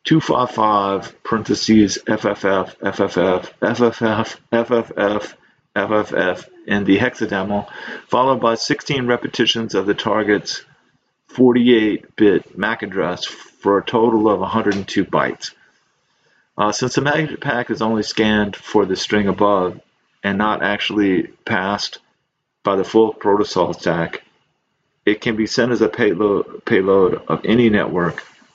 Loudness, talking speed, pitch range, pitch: -18 LUFS, 125 wpm, 100-120 Hz, 110 Hz